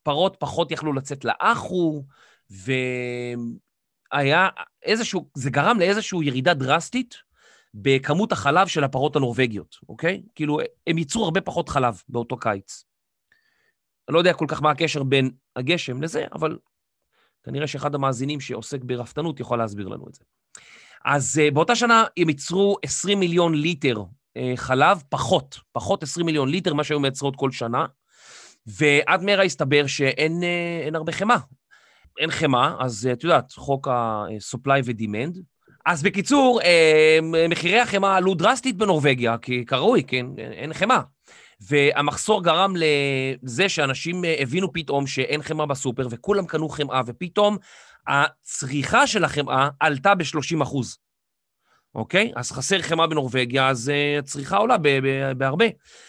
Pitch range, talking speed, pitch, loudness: 135-175 Hz, 135 wpm, 150 Hz, -22 LUFS